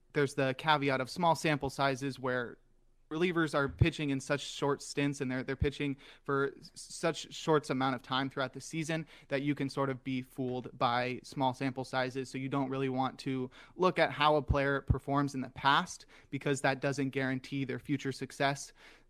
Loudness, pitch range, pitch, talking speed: -33 LUFS, 130-145 Hz, 140 Hz, 190 wpm